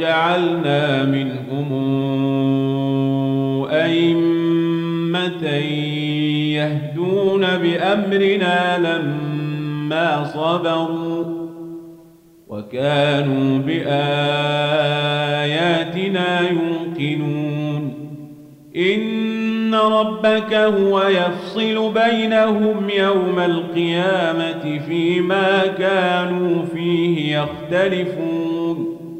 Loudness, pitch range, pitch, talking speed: -18 LUFS, 150-180 Hz, 165 Hz, 45 wpm